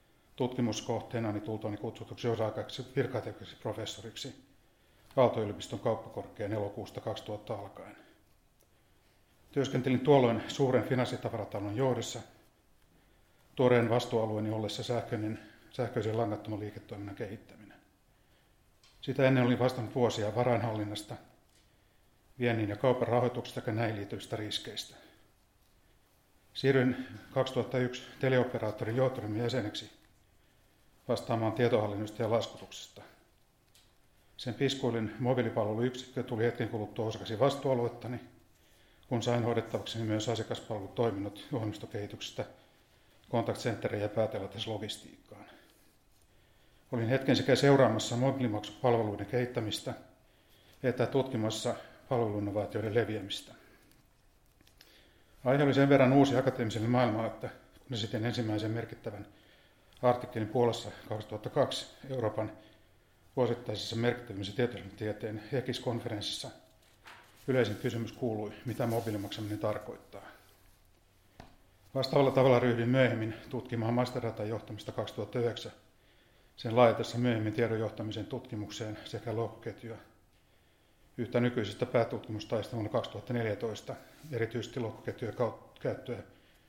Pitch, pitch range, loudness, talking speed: 115 Hz, 105-125 Hz, -33 LUFS, 90 wpm